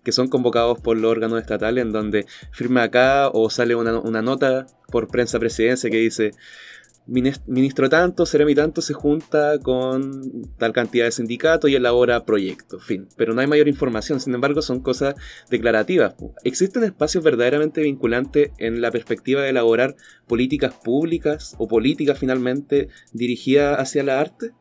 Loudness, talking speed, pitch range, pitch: -20 LUFS, 155 wpm, 120-145 Hz, 130 Hz